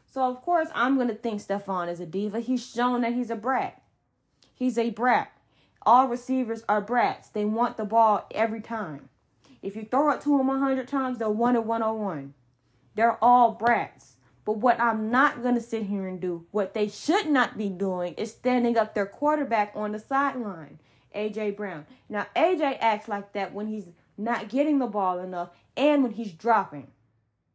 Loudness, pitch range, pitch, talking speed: -26 LUFS, 205-250 Hz, 225 Hz, 190 wpm